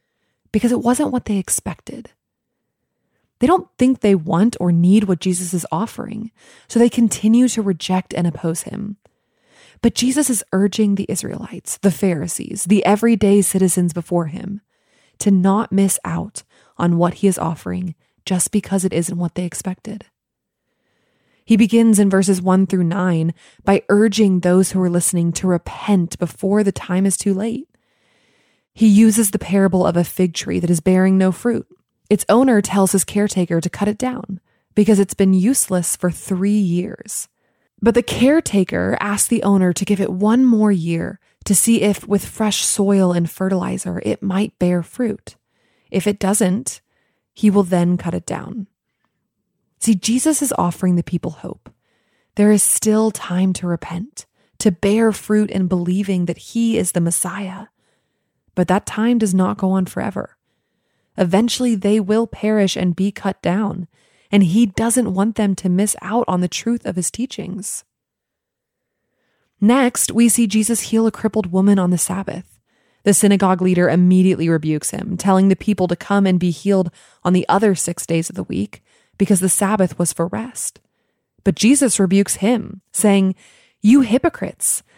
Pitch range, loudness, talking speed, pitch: 180-215 Hz, -17 LUFS, 165 wpm, 195 Hz